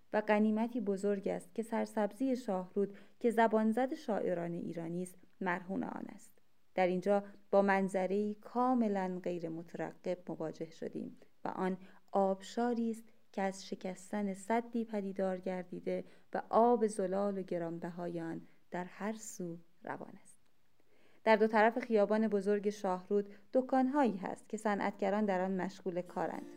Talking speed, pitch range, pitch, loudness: 135 wpm, 185-225 Hz, 200 Hz, -35 LUFS